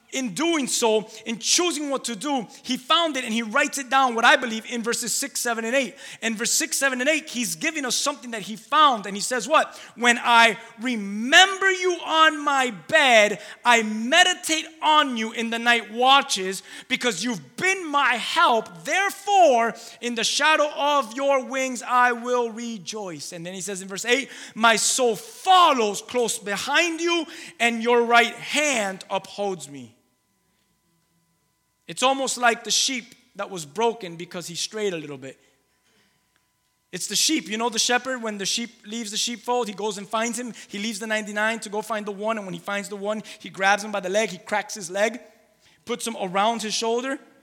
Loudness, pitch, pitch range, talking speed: -22 LUFS, 235 Hz, 210-270 Hz, 195 wpm